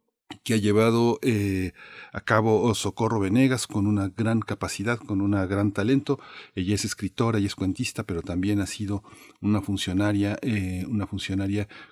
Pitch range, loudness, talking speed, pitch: 100-115 Hz, -25 LUFS, 155 wpm, 105 Hz